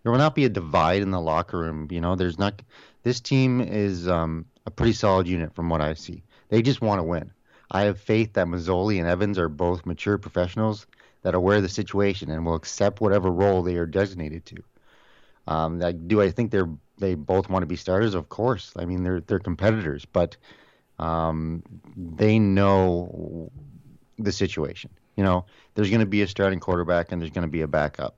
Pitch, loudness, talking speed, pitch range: 95 Hz, -24 LUFS, 210 wpm, 85-105 Hz